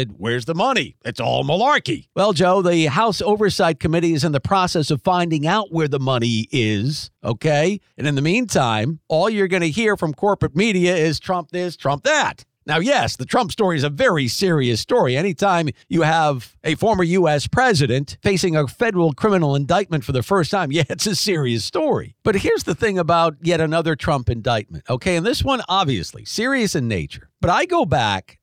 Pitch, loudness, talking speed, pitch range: 165 Hz, -19 LUFS, 195 wpm, 140-190 Hz